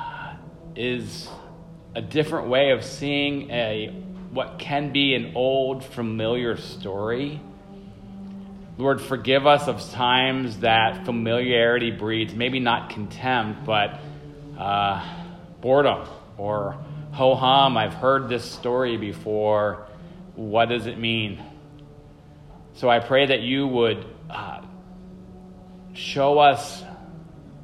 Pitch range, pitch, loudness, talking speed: 115-150 Hz, 130 Hz, -23 LUFS, 105 wpm